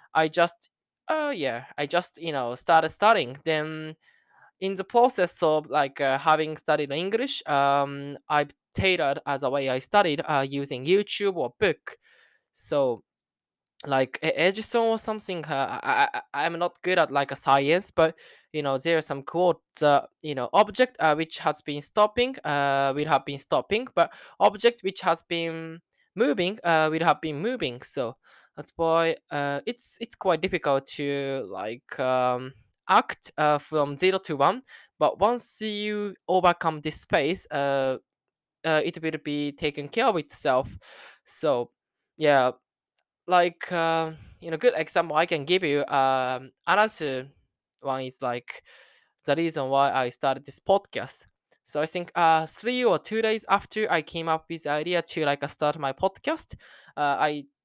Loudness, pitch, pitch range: -25 LUFS, 160 Hz, 140-190 Hz